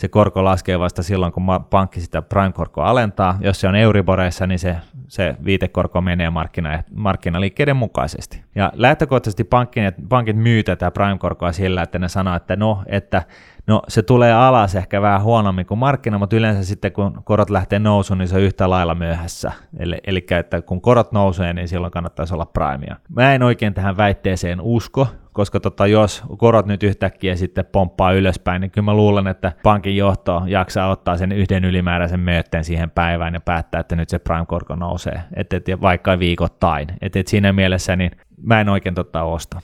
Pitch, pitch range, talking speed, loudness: 95 Hz, 90-105 Hz, 185 wpm, -18 LUFS